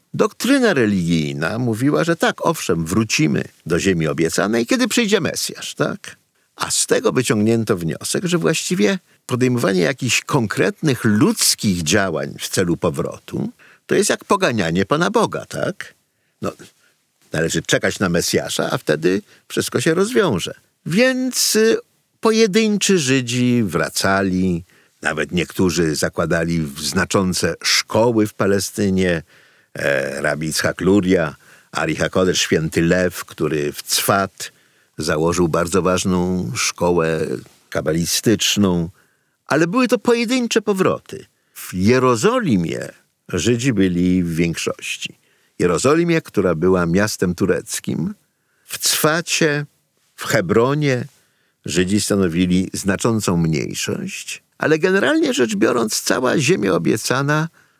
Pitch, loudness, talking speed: 115 Hz, -18 LUFS, 105 wpm